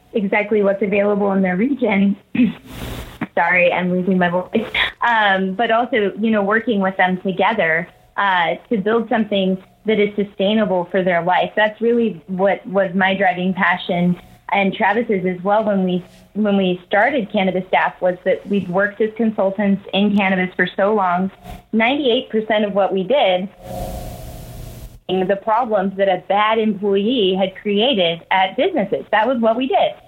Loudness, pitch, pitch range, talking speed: -17 LUFS, 200 Hz, 185-220 Hz, 160 wpm